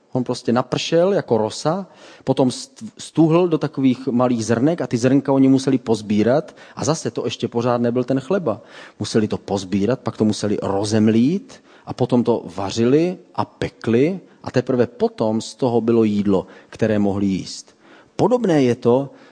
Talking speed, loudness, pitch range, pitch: 160 wpm, -19 LUFS, 110-140 Hz, 125 Hz